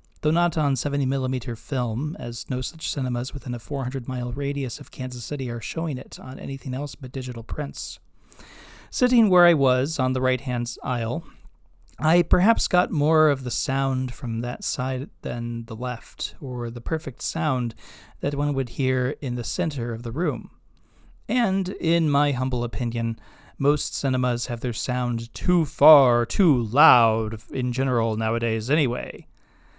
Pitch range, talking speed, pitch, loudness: 120-145 Hz, 165 wpm, 130 Hz, -24 LUFS